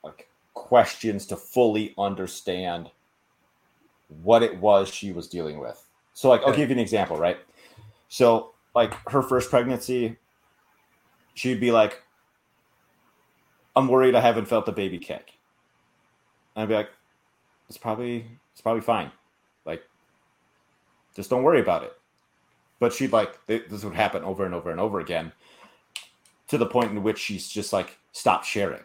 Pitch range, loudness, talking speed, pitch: 100-120 Hz, -24 LUFS, 150 wpm, 110 Hz